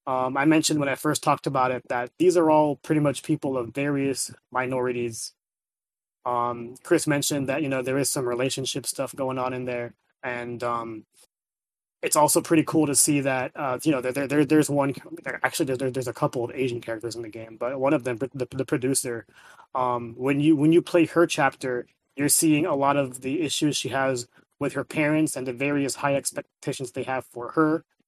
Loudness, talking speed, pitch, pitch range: -25 LUFS, 215 wpm, 135 Hz, 125-150 Hz